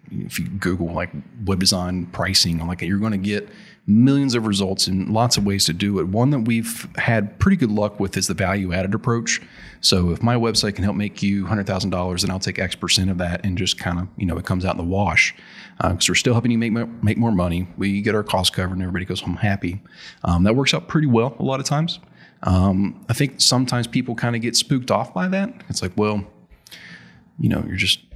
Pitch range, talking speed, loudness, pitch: 95-115 Hz, 240 wpm, -20 LUFS, 100 Hz